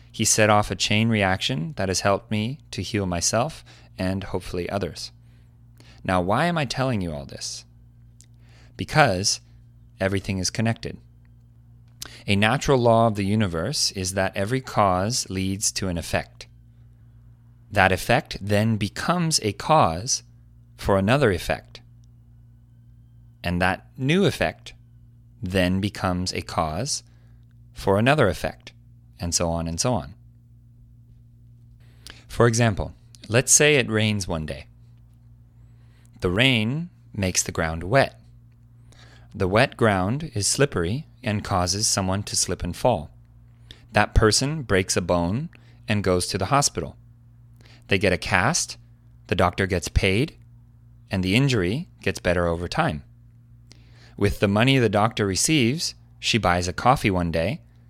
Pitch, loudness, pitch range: 115 Hz, -23 LUFS, 100-120 Hz